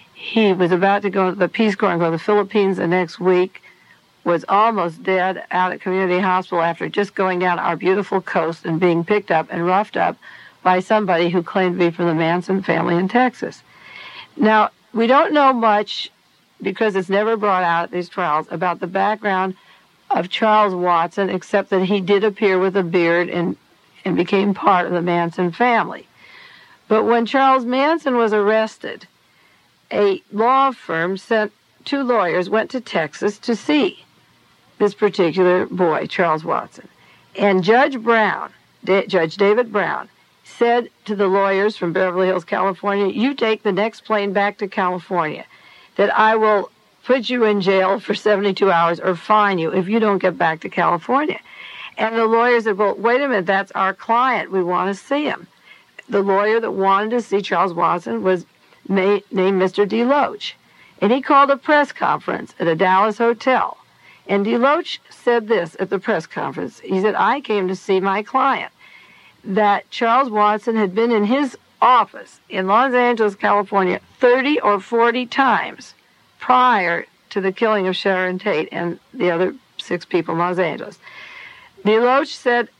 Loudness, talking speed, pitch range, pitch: -18 LUFS, 170 wpm, 185-225 Hz, 200 Hz